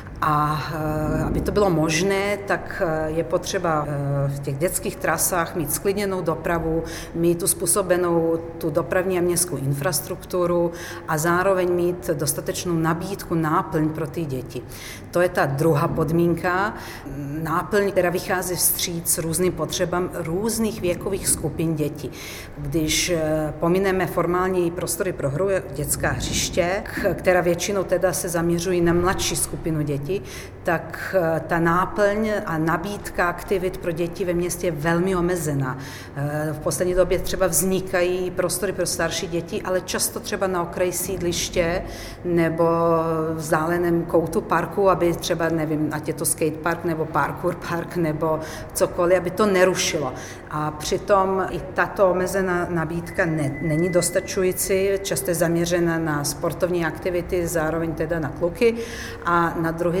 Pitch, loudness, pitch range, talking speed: 170 Hz, -22 LUFS, 160-185 Hz, 135 wpm